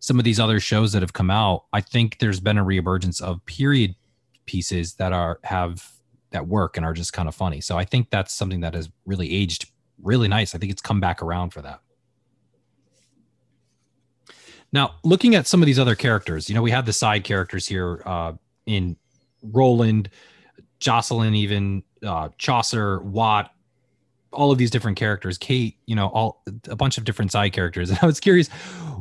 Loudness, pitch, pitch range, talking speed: -22 LUFS, 105 Hz, 90-120 Hz, 190 wpm